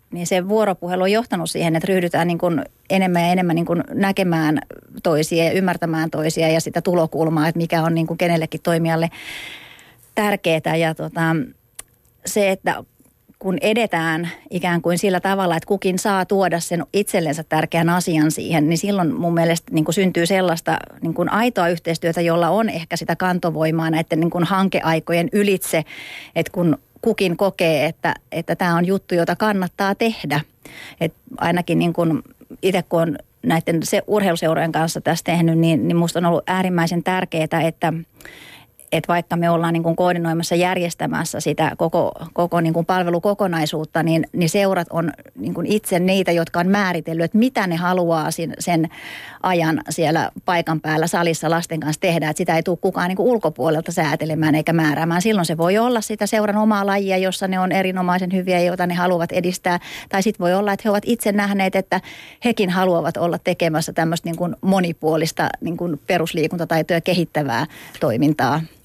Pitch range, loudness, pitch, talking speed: 165-185 Hz, -19 LUFS, 170 Hz, 165 wpm